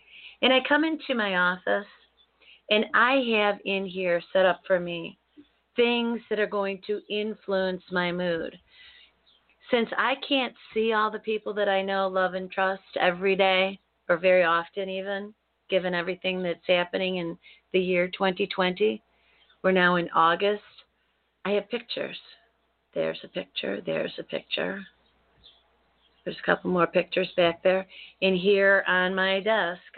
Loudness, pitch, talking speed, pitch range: -26 LUFS, 190 Hz, 150 wpm, 180-210 Hz